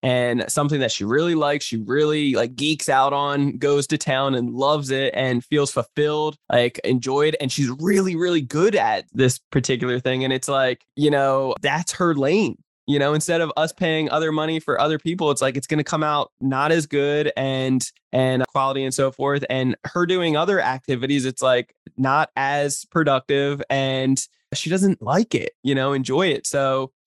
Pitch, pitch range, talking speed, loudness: 140 Hz, 130-150 Hz, 195 wpm, -21 LUFS